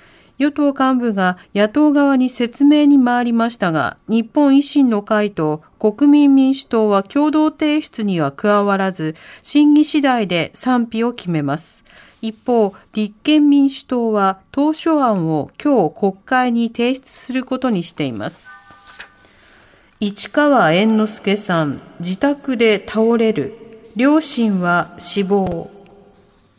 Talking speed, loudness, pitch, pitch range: 225 characters per minute, -16 LUFS, 225 Hz, 190-270 Hz